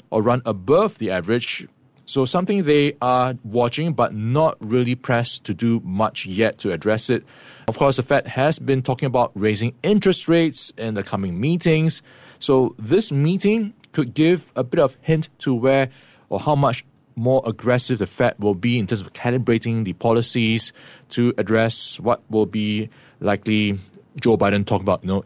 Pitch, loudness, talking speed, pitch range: 125 Hz, -20 LUFS, 175 wpm, 110-140 Hz